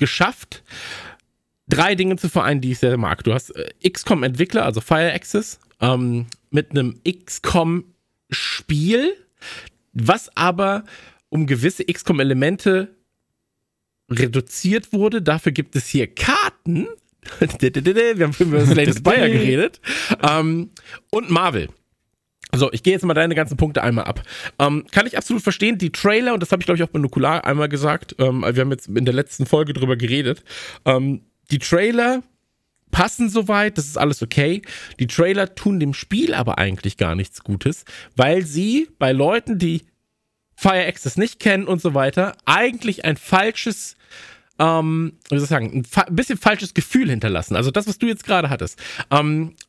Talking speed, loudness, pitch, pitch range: 160 wpm, -19 LUFS, 160 Hz, 135-195 Hz